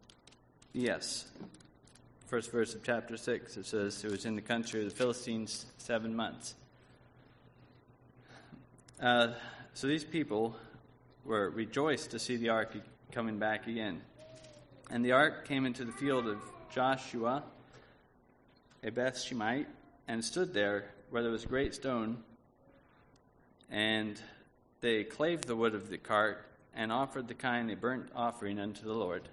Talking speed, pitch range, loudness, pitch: 140 wpm, 110-125 Hz, -35 LUFS, 120 Hz